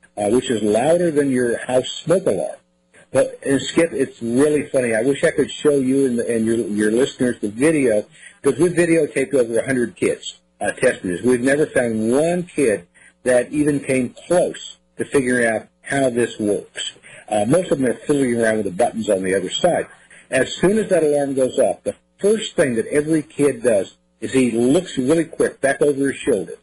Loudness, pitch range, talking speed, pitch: -19 LUFS, 115-150 Hz, 205 wpm, 130 Hz